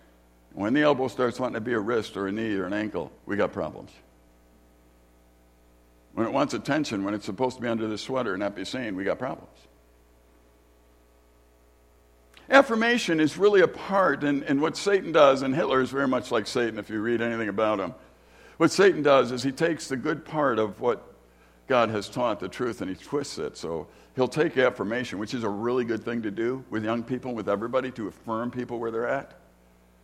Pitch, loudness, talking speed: 115 Hz, -26 LUFS, 205 wpm